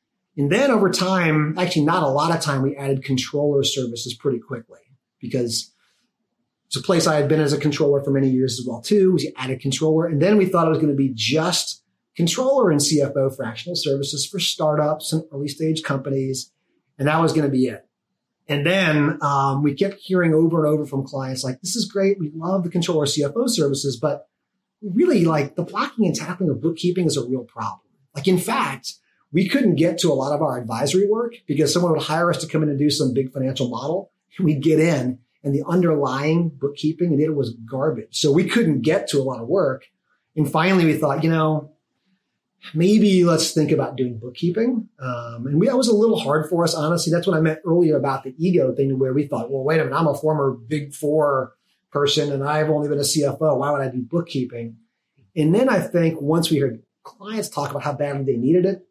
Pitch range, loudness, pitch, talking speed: 140-175 Hz, -20 LUFS, 155 Hz, 220 wpm